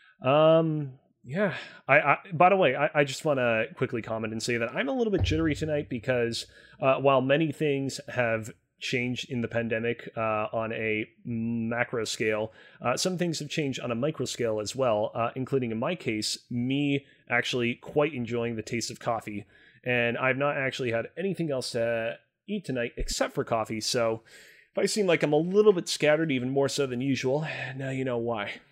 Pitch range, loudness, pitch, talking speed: 115-145 Hz, -28 LUFS, 130 Hz, 195 wpm